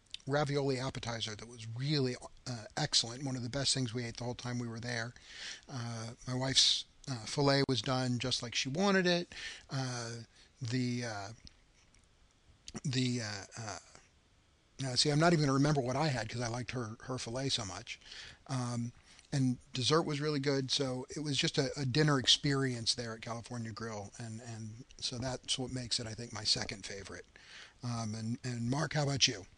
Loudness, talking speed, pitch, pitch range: -34 LUFS, 190 wpm, 125 Hz, 115-135 Hz